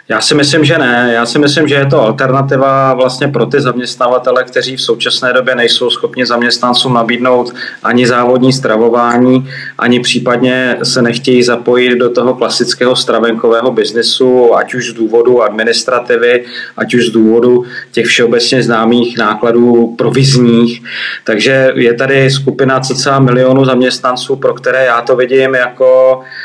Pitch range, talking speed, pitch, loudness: 120-130 Hz, 145 wpm, 125 Hz, -9 LUFS